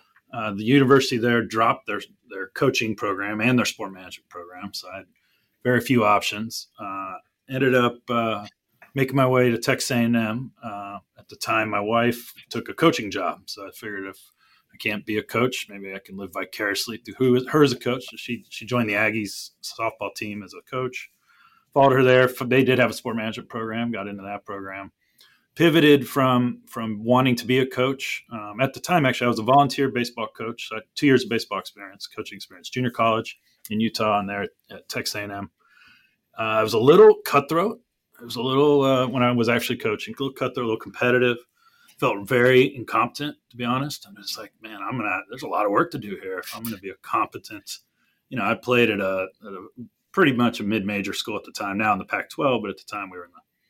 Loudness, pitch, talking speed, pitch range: -22 LUFS, 120 Hz, 230 wpm, 110-130 Hz